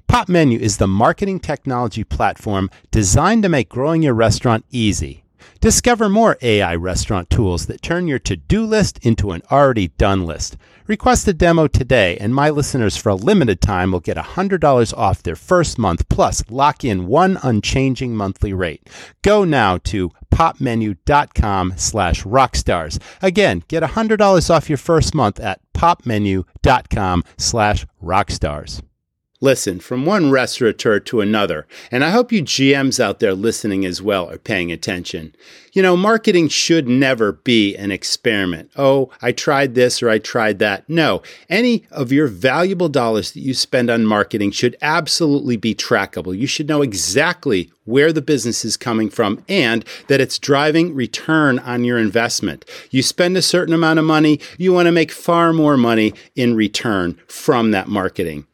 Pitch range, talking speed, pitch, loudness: 100-155 Hz, 160 wpm, 120 Hz, -16 LUFS